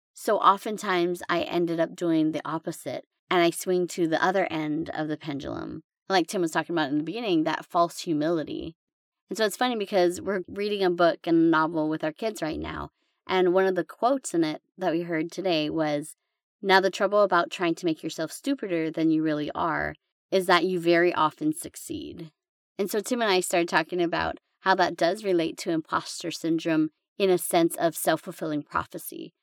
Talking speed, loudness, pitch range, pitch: 200 wpm, -26 LUFS, 160-190 Hz, 175 Hz